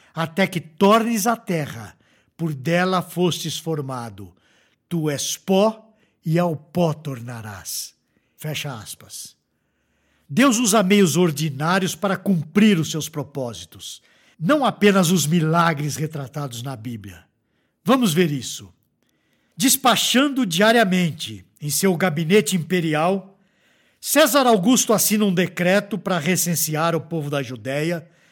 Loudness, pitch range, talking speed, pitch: -20 LUFS, 145-195 Hz, 115 wpm, 170 Hz